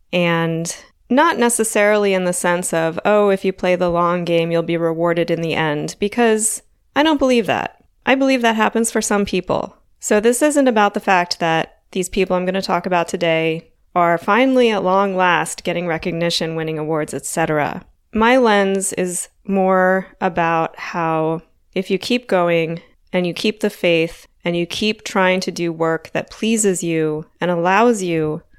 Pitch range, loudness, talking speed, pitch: 170-210 Hz, -18 LUFS, 180 wpm, 180 Hz